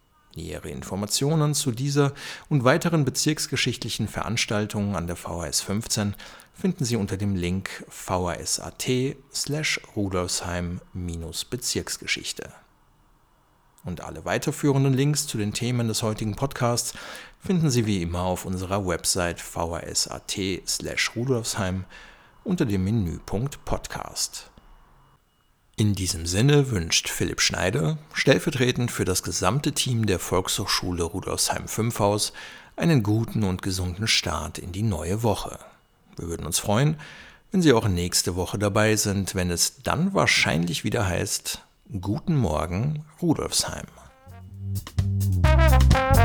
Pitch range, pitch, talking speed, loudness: 90-130 Hz, 105 Hz, 110 wpm, -25 LUFS